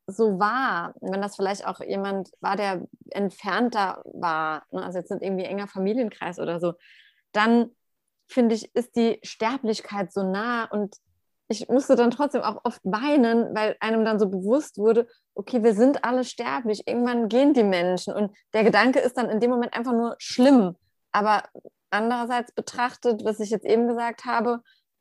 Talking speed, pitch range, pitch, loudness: 170 wpm, 200-245 Hz, 225 Hz, -24 LUFS